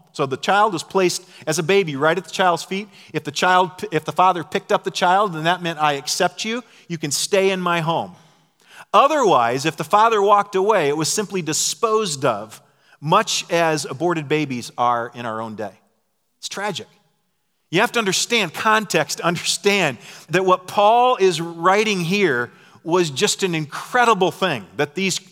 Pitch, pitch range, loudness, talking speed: 180 Hz, 155-195 Hz, -19 LUFS, 180 wpm